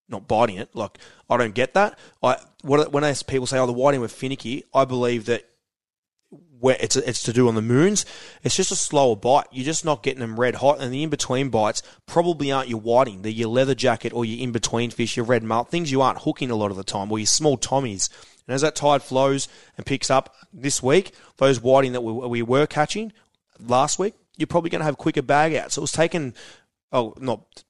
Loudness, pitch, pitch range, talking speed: -22 LUFS, 130 Hz, 120-145 Hz, 230 wpm